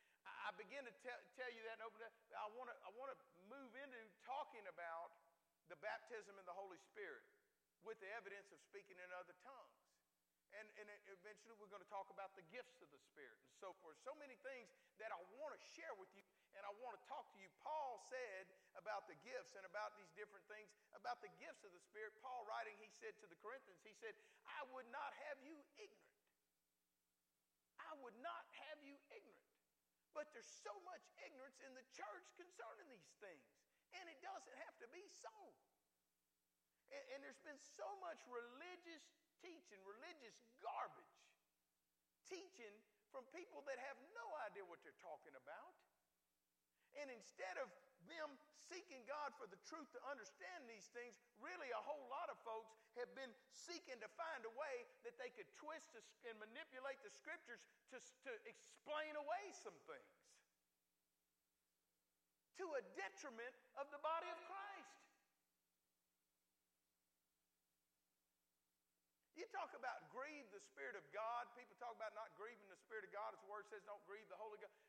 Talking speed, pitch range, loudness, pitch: 170 wpm, 185-300 Hz, -56 LUFS, 235 Hz